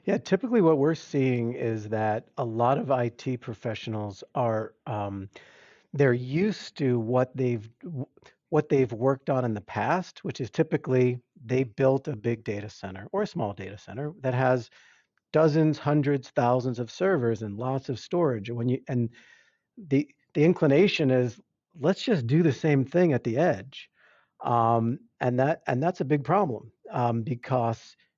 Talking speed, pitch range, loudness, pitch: 160 wpm, 115-155 Hz, -27 LUFS, 130 Hz